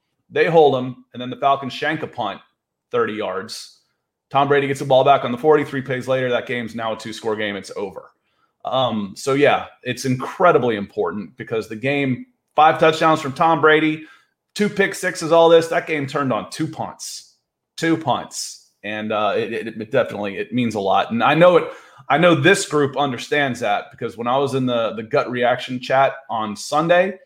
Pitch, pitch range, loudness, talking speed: 140 Hz, 125-155 Hz, -19 LUFS, 195 wpm